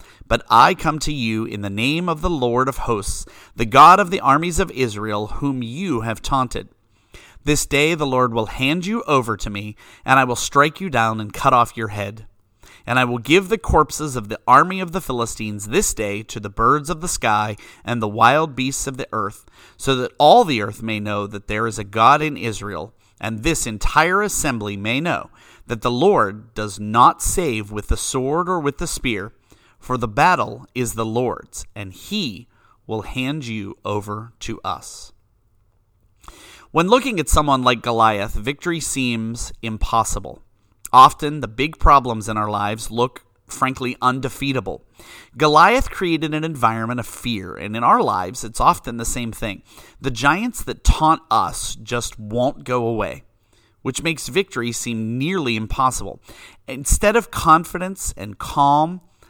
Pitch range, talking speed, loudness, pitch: 110-145 Hz, 175 wpm, -19 LUFS, 120 Hz